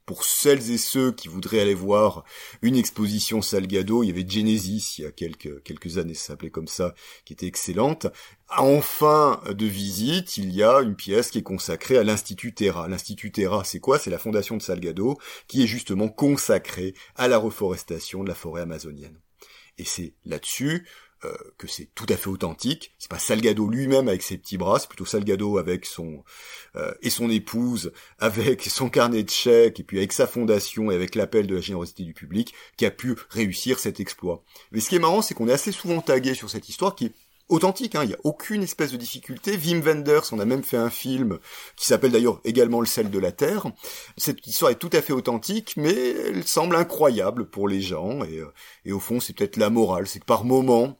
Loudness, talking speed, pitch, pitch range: -24 LUFS, 215 wpm, 110 Hz, 95-130 Hz